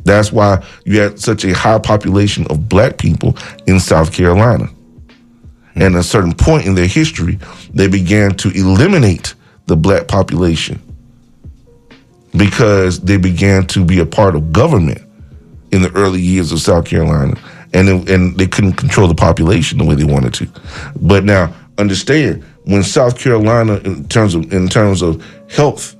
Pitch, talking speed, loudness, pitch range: 95 Hz, 165 wpm, -12 LUFS, 85-105 Hz